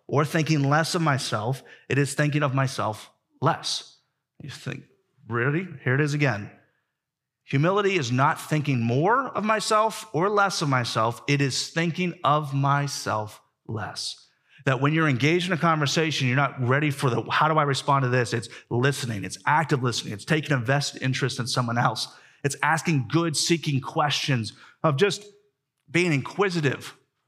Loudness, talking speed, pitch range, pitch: -24 LUFS, 165 wpm, 130-160 Hz, 140 Hz